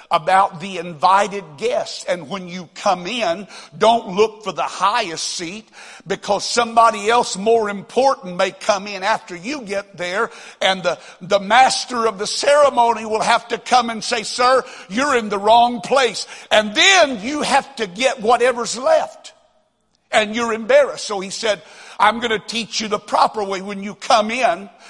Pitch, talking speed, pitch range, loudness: 220 Hz, 175 wpm, 200-245 Hz, -18 LUFS